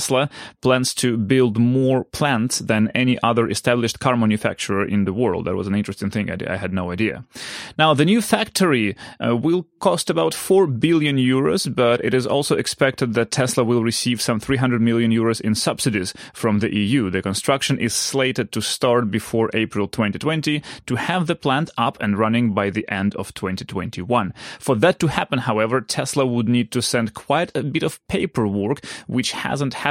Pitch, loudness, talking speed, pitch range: 120 Hz, -20 LUFS, 190 wpm, 110-135 Hz